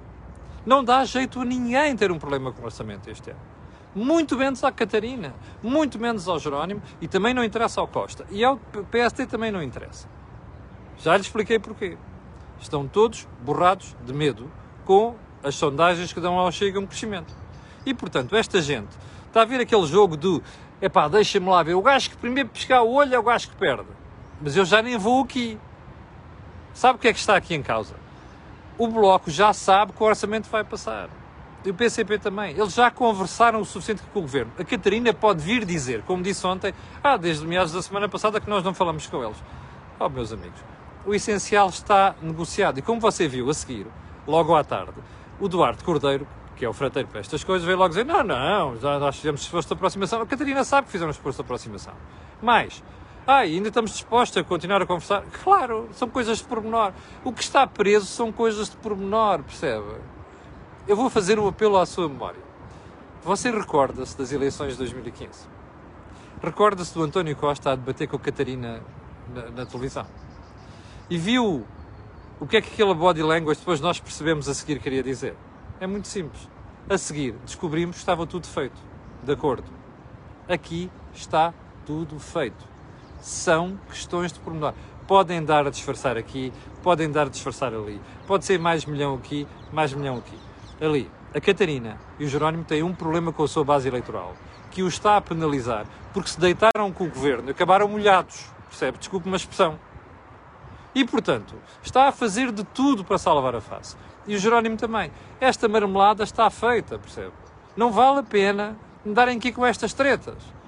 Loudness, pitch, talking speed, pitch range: -23 LUFS, 185 Hz, 185 wpm, 145-220 Hz